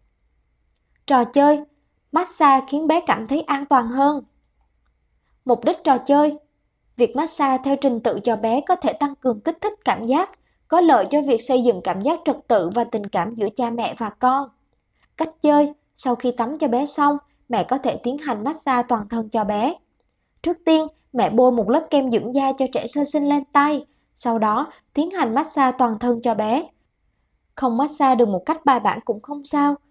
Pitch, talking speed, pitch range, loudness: 270 Hz, 200 wpm, 235-295 Hz, -20 LUFS